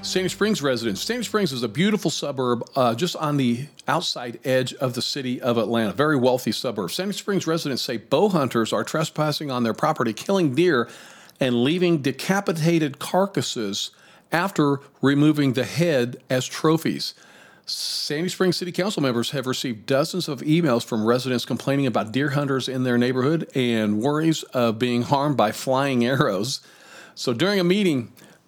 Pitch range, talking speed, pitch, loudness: 125-165 Hz, 165 wpm, 140 Hz, -23 LUFS